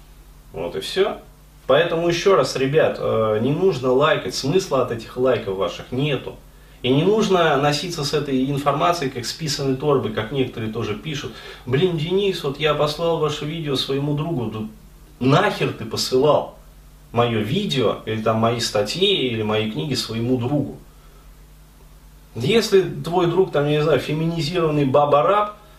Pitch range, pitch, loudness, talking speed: 120-165 Hz, 140 Hz, -20 LUFS, 150 wpm